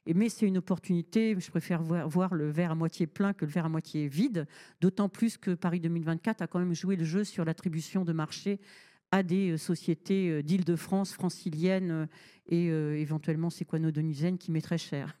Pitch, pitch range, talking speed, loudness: 175 Hz, 160-190 Hz, 175 wpm, -31 LUFS